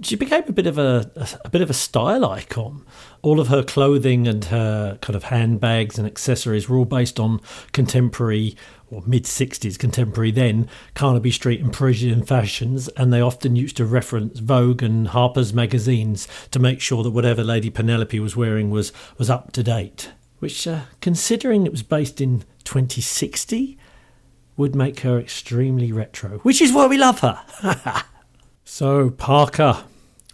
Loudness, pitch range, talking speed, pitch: -20 LUFS, 115-135 Hz, 165 wpm, 125 Hz